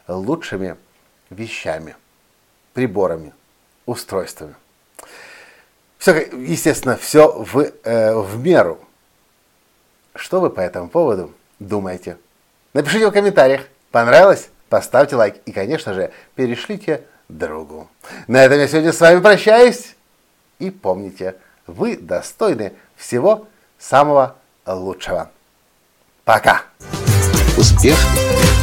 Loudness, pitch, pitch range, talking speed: -15 LUFS, 130 Hz, 95-160 Hz, 90 wpm